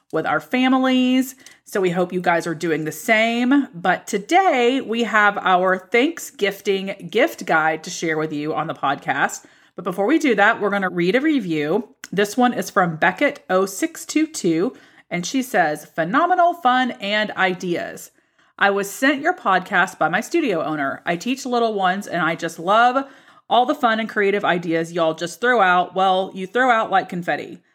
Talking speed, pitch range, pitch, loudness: 180 wpm, 180-255 Hz, 200 Hz, -19 LUFS